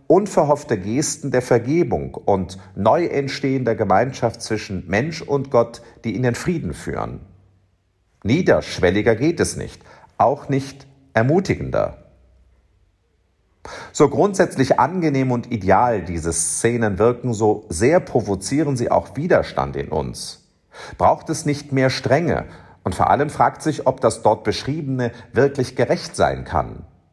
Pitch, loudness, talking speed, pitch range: 120 Hz, -20 LUFS, 130 wpm, 95-140 Hz